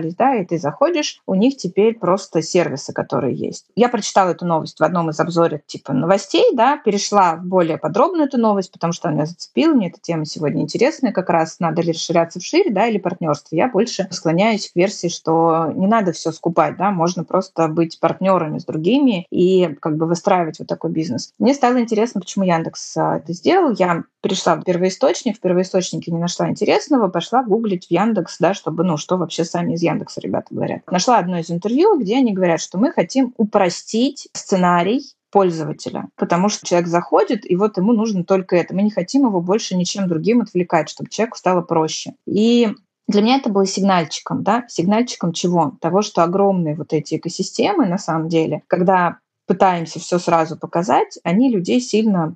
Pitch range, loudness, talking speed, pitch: 165-215 Hz, -18 LUFS, 185 wpm, 185 Hz